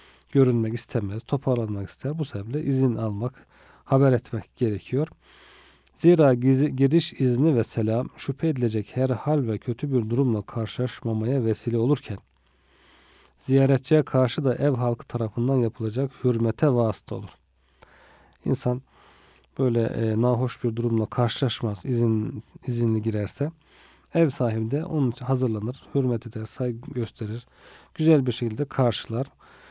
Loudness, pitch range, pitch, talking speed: -25 LUFS, 115-135 Hz, 125 Hz, 125 wpm